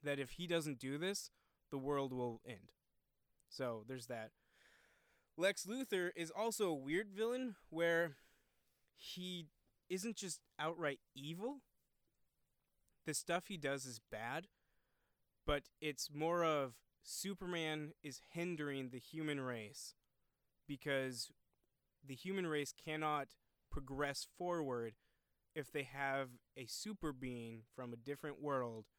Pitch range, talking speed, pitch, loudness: 130-170 Hz, 120 wpm, 150 Hz, -44 LUFS